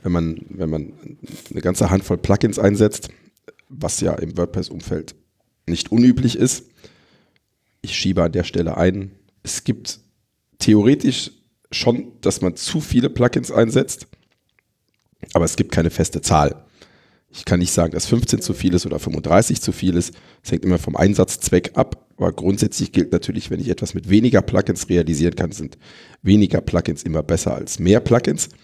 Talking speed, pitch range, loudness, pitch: 165 wpm, 85-105 Hz, -19 LUFS, 95 Hz